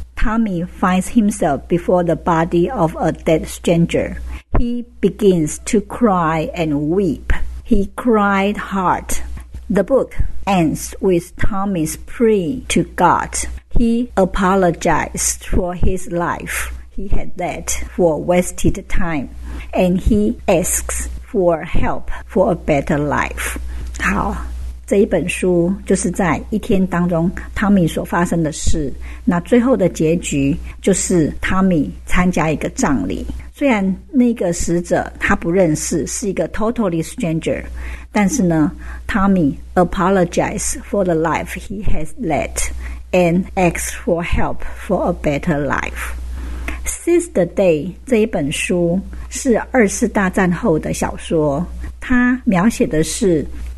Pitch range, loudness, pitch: 155-200 Hz, -17 LUFS, 175 Hz